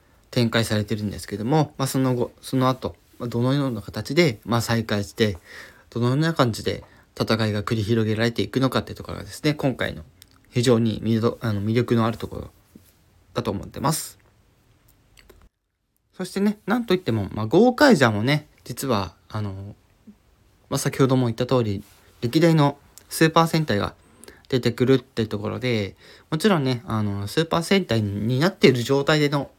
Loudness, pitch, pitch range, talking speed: -22 LUFS, 115 Hz, 105-135 Hz, 340 characters per minute